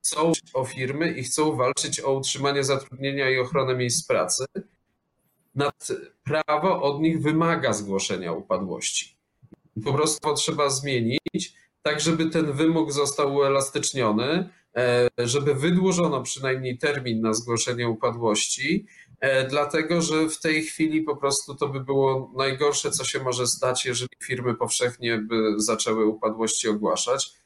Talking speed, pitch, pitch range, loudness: 130 wpm, 140 Hz, 125-155 Hz, -24 LUFS